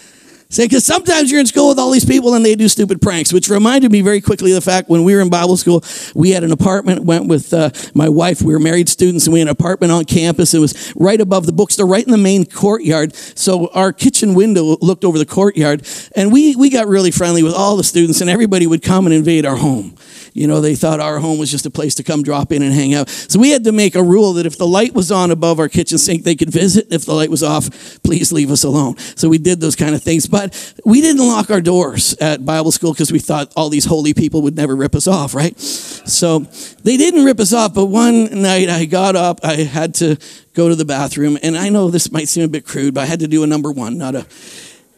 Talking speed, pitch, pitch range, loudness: 265 wpm, 170 Hz, 155-195 Hz, -12 LUFS